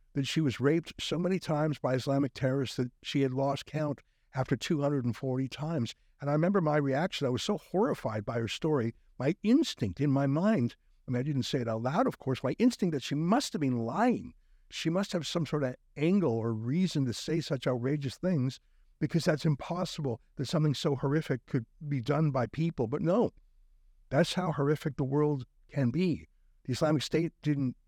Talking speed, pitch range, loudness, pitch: 200 wpm, 130-160 Hz, -31 LUFS, 140 Hz